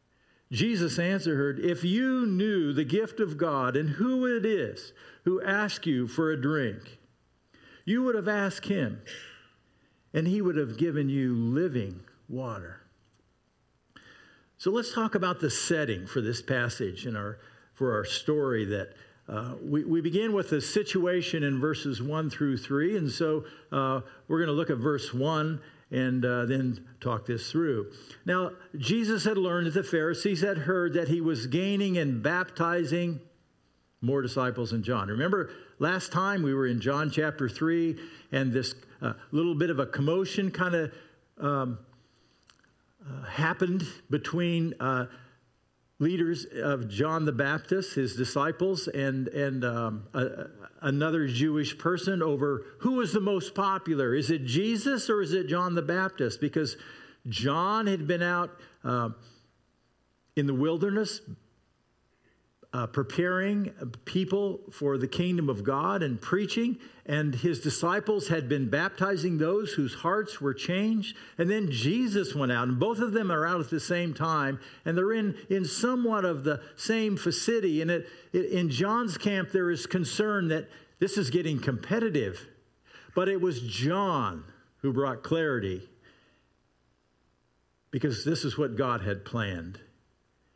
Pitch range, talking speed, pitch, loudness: 130-185 Hz, 150 wpm, 155 Hz, -29 LUFS